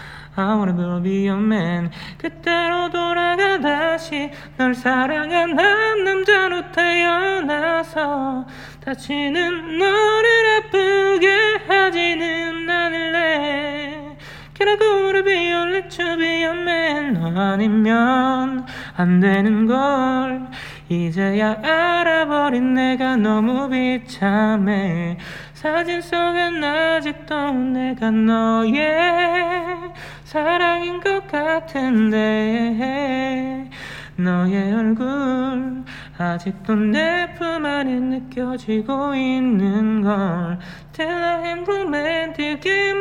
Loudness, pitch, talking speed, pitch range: -19 LUFS, 290 Hz, 205 characters per minute, 225-345 Hz